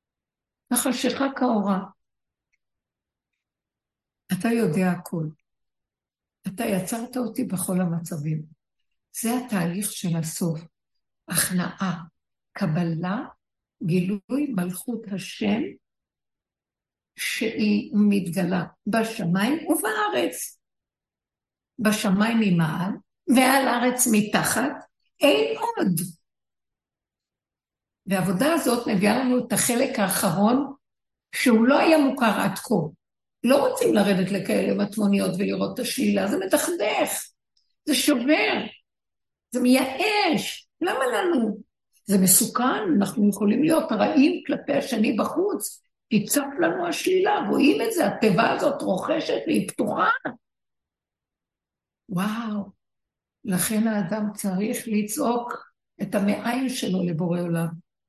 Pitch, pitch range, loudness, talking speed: 215 Hz, 190-260 Hz, -23 LUFS, 95 wpm